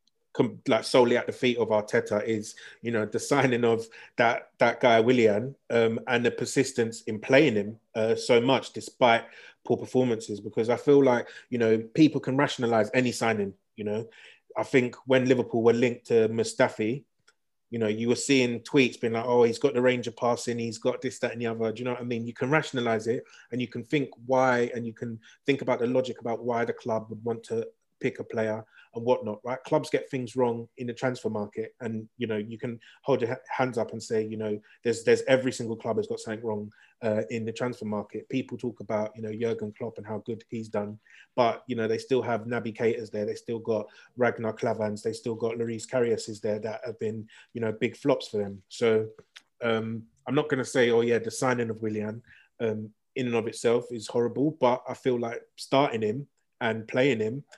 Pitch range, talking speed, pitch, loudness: 110-125 Hz, 220 wpm, 115 Hz, -27 LUFS